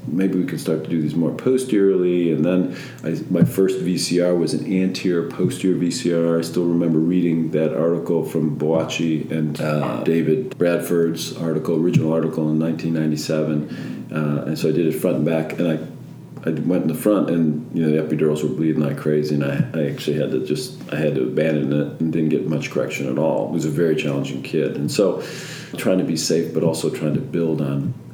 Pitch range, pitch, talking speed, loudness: 75-85 Hz, 80 Hz, 210 wpm, -20 LUFS